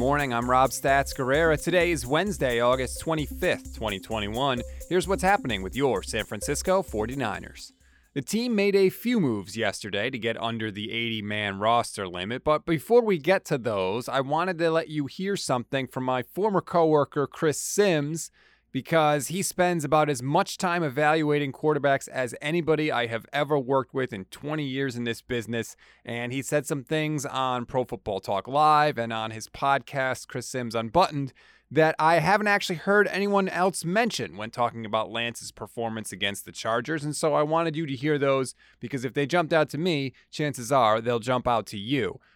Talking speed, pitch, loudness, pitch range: 185 wpm, 140 Hz, -26 LUFS, 120-160 Hz